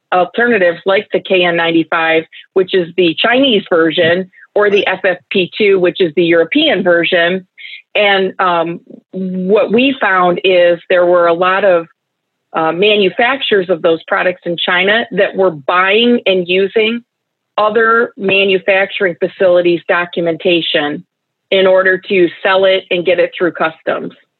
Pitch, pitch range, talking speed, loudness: 185 Hz, 175-200 Hz, 135 wpm, -12 LUFS